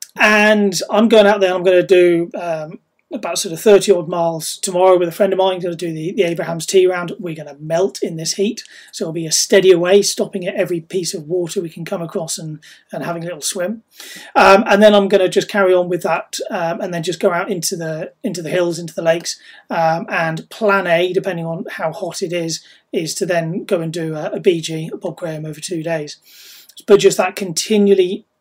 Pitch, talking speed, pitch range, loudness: 180 Hz, 245 wpm, 165-200 Hz, -16 LUFS